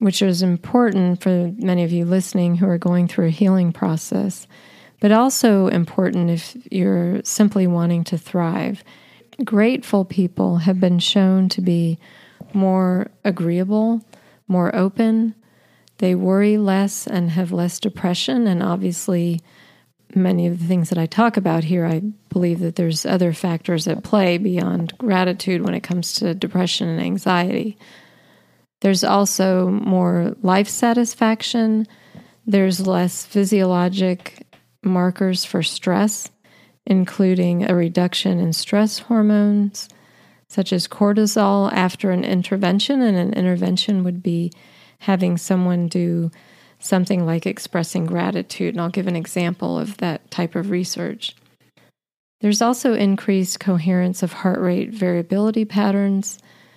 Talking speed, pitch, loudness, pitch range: 130 wpm, 185 Hz, -19 LUFS, 175-205 Hz